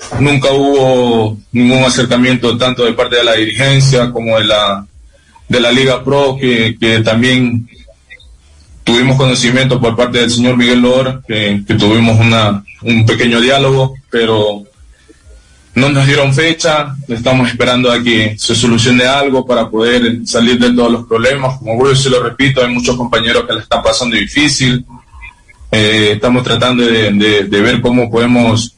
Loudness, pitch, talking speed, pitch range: -10 LUFS, 120 Hz, 160 wpm, 115-130 Hz